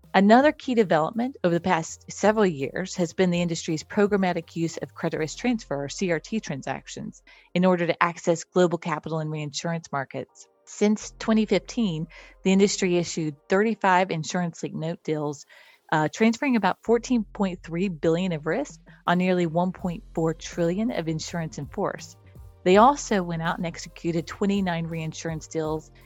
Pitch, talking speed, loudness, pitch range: 175 Hz, 145 wpm, -25 LUFS, 160-195 Hz